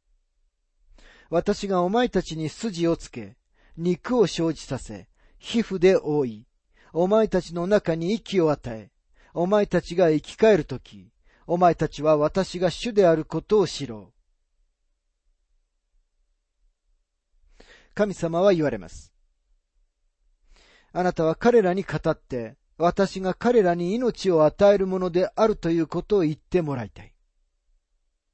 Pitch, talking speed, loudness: 160 Hz, 230 characters per minute, -23 LUFS